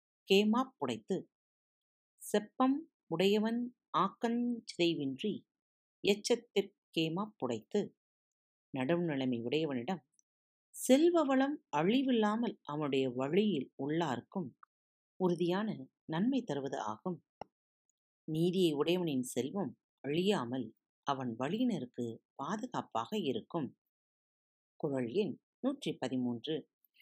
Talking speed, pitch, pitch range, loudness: 65 wpm, 180 Hz, 140-225 Hz, -35 LUFS